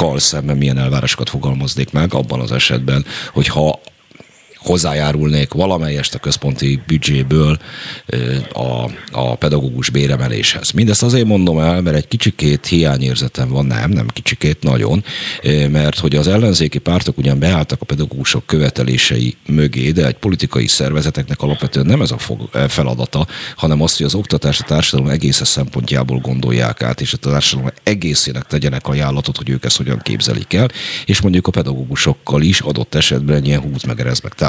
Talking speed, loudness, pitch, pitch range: 145 wpm, -15 LUFS, 70 Hz, 65-75 Hz